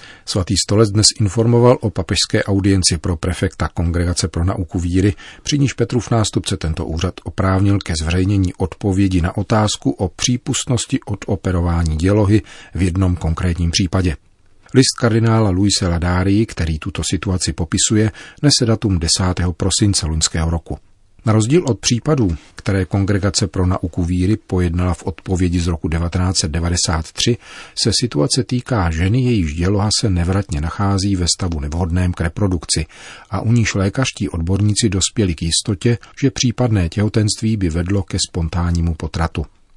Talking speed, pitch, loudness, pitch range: 140 wpm, 95 Hz, -17 LUFS, 90-110 Hz